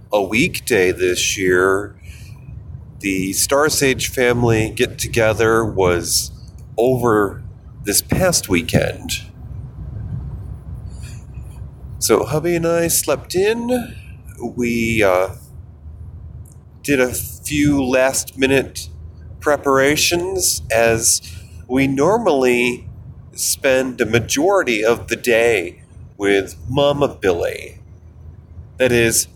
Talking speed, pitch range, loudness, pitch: 85 wpm, 95-130 Hz, -17 LUFS, 115 Hz